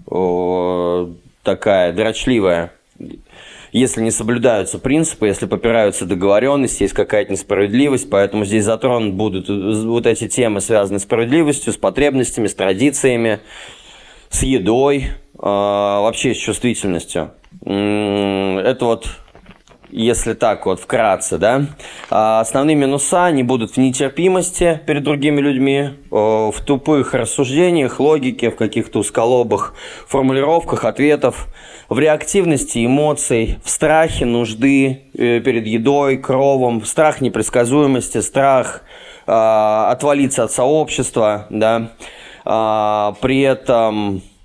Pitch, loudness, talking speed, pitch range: 120 Hz, -16 LUFS, 105 wpm, 105-140 Hz